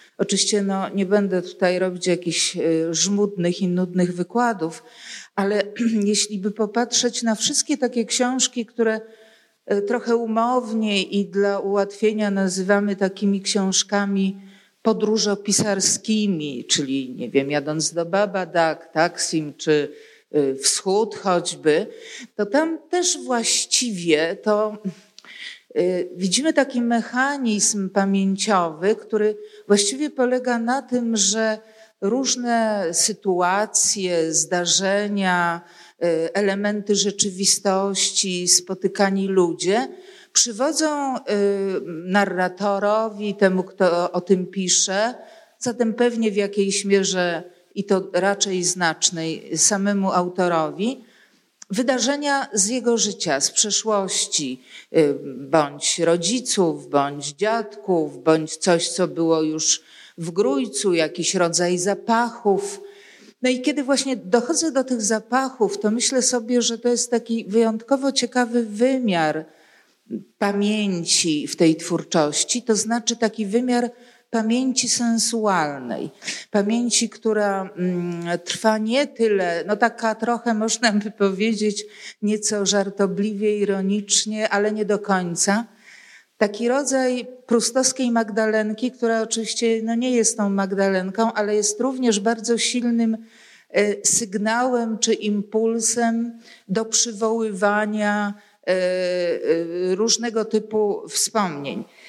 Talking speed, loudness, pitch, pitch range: 100 wpm, -21 LUFS, 210 Hz, 185-230 Hz